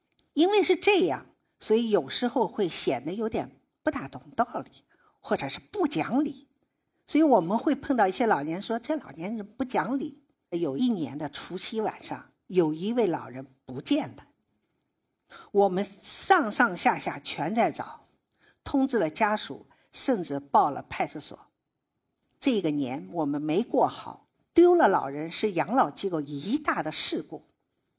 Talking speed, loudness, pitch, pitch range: 225 characters per minute, -27 LUFS, 230 Hz, 180-295 Hz